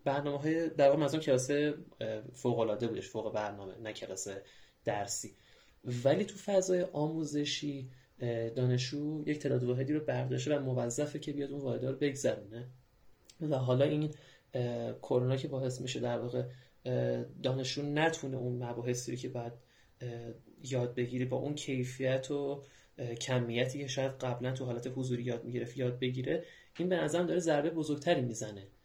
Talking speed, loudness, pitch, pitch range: 145 wpm, -35 LUFS, 130 Hz, 120-145 Hz